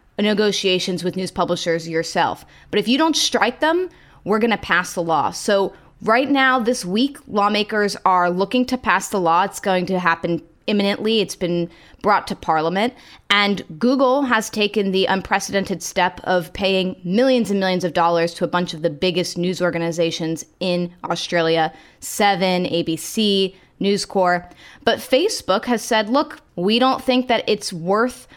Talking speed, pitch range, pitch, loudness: 165 wpm, 175-220 Hz, 190 Hz, -19 LUFS